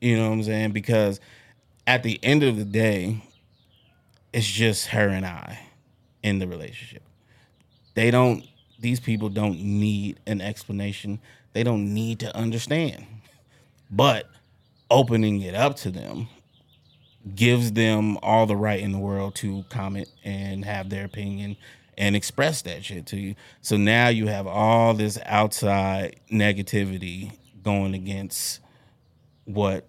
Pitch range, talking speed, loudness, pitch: 100-115 Hz, 140 wpm, -24 LUFS, 105 Hz